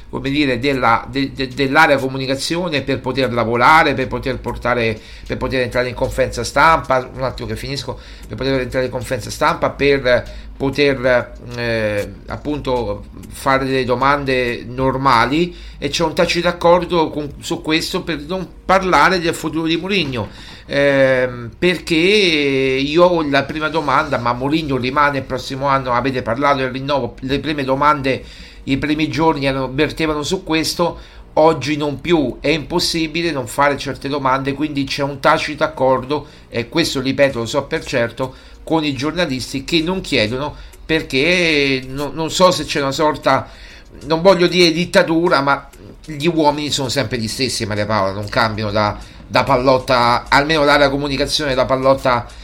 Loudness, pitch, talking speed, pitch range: -17 LUFS, 140 Hz, 155 wpm, 130-155 Hz